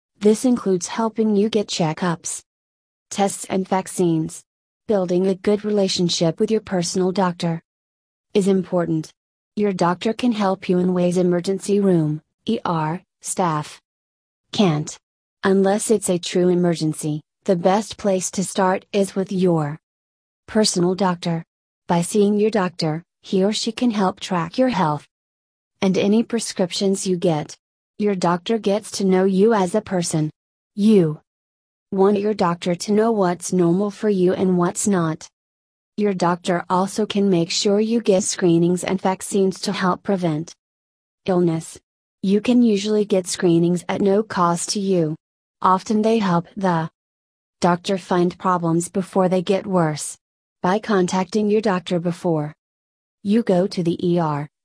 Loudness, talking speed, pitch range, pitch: -20 LUFS, 145 wpm, 170-200 Hz, 185 Hz